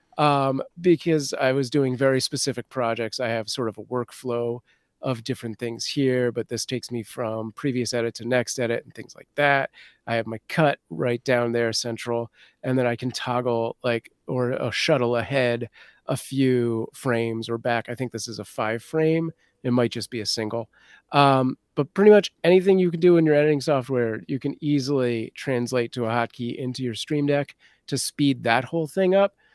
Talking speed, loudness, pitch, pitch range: 195 wpm, -24 LUFS, 125 Hz, 115-140 Hz